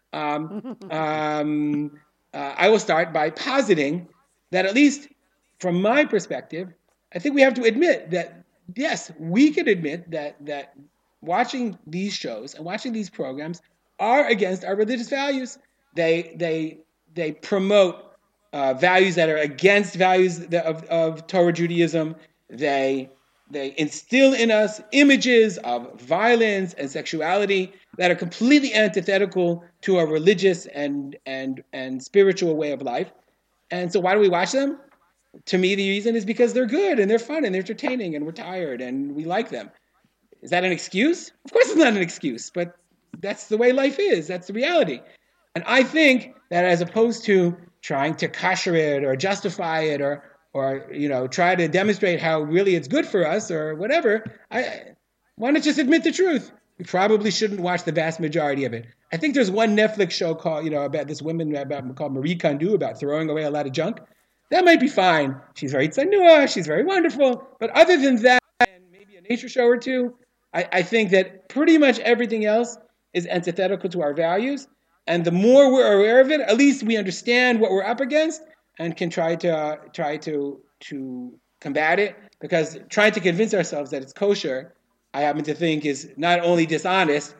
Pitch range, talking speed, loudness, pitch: 155-235 Hz, 185 wpm, -21 LUFS, 185 Hz